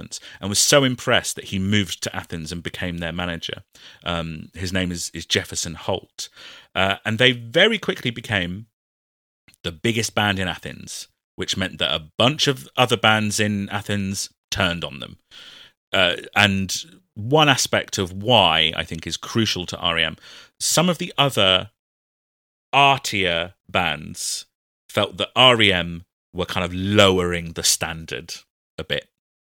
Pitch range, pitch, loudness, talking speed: 85-115 Hz, 100 Hz, -20 LUFS, 150 wpm